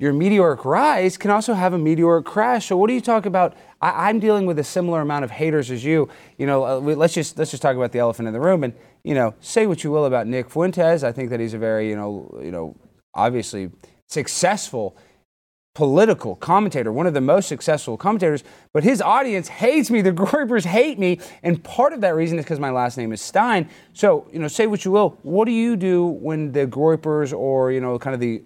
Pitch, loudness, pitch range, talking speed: 160 Hz, -20 LUFS, 130-190 Hz, 235 wpm